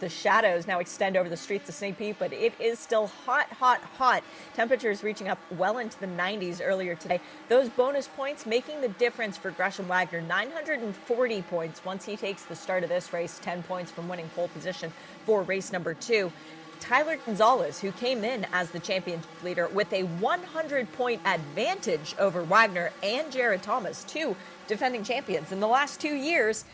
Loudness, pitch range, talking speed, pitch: -28 LUFS, 180-250 Hz, 185 wpm, 200 Hz